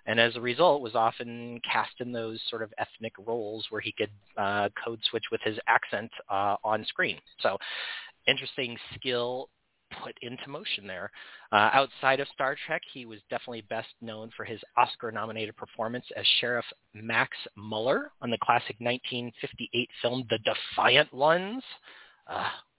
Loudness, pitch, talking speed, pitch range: -29 LUFS, 120 Hz, 155 wpm, 110-130 Hz